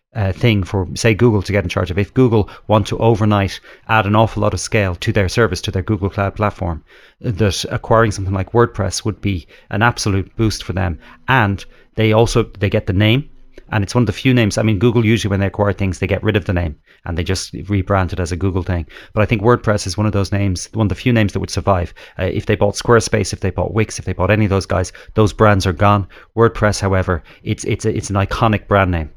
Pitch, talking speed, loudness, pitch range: 100 Hz, 255 wpm, -17 LUFS, 95-110 Hz